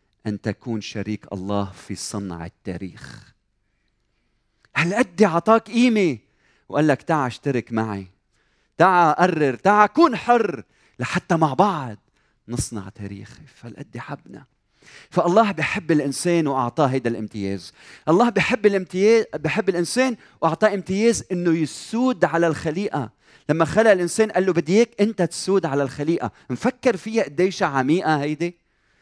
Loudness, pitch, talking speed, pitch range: -21 LUFS, 155 Hz, 125 wpm, 115-195 Hz